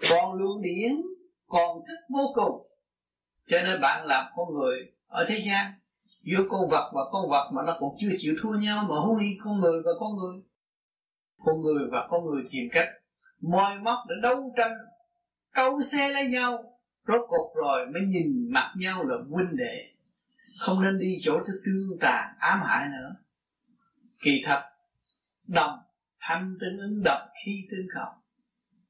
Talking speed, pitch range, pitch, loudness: 170 wpm, 180-245 Hz, 200 Hz, -27 LUFS